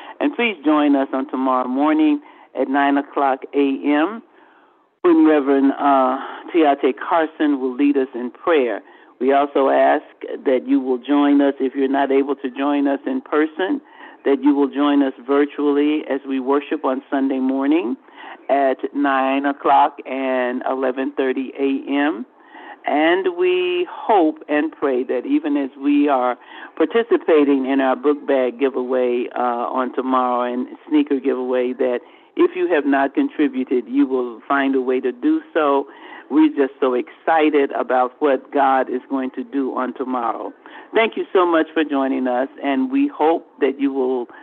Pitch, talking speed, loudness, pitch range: 140 Hz, 160 wpm, -19 LUFS, 130-155 Hz